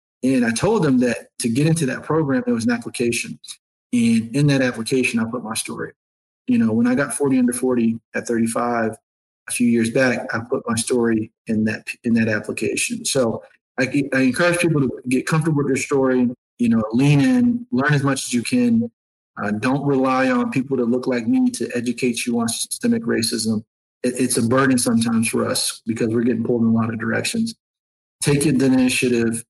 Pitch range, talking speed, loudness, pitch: 115-145 Hz, 205 wpm, -20 LUFS, 125 Hz